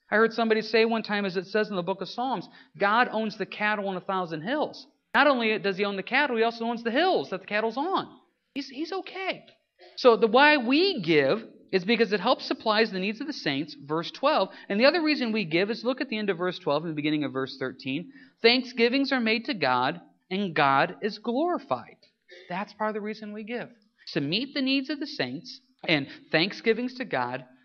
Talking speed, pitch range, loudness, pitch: 230 wpm, 190-255 Hz, -26 LUFS, 220 Hz